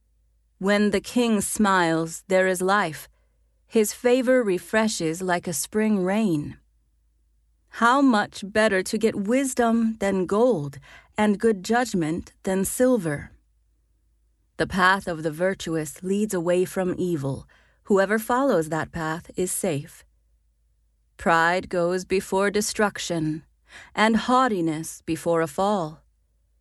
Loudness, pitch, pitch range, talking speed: -23 LUFS, 185 Hz, 155-210 Hz, 115 wpm